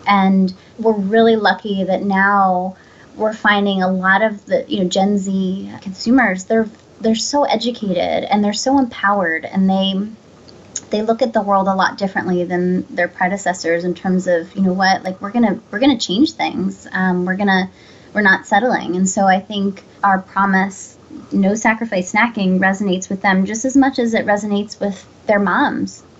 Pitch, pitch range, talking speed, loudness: 195 Hz, 190-220 Hz, 180 wpm, -16 LUFS